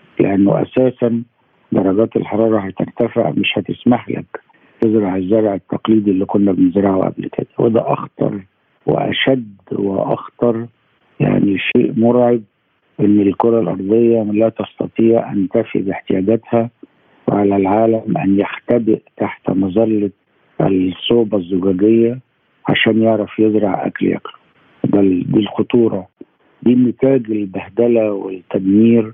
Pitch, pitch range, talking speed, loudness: 110 Hz, 100-115 Hz, 105 wpm, -16 LUFS